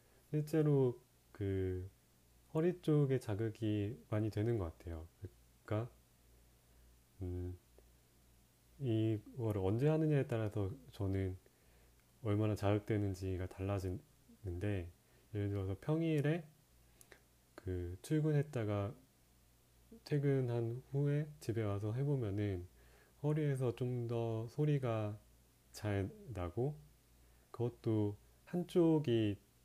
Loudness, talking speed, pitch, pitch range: -39 LUFS, 195 characters per minute, 105 Hz, 90-130 Hz